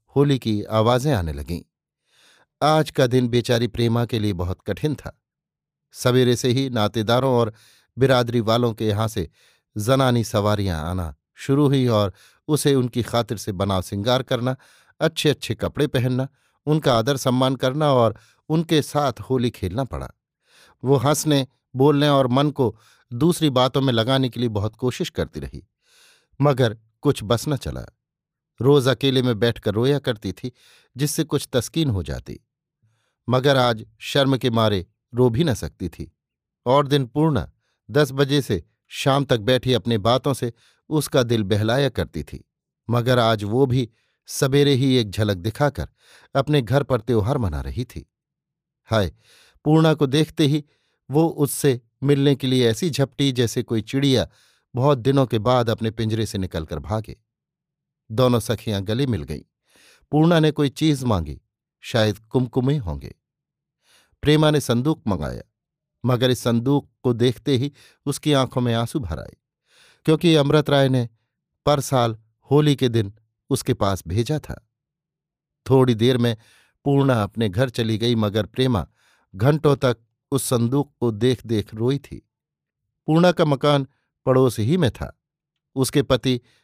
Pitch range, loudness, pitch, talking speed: 110-145 Hz, -21 LUFS, 125 Hz, 155 wpm